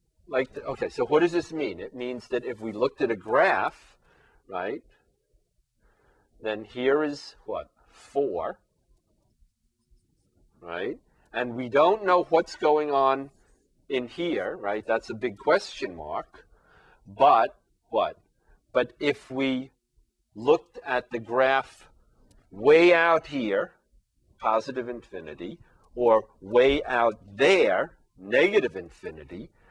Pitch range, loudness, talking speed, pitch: 120-155 Hz, -25 LUFS, 115 wpm, 135 Hz